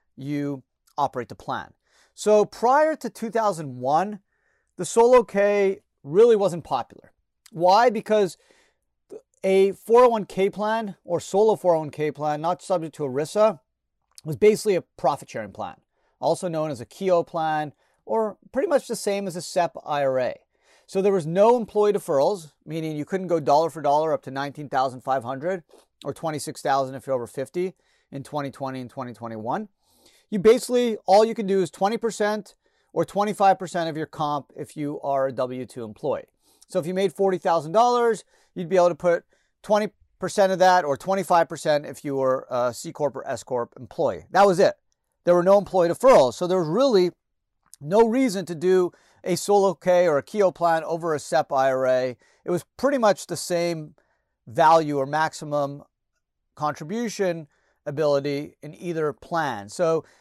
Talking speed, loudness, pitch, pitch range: 175 wpm, -23 LUFS, 175 Hz, 145-205 Hz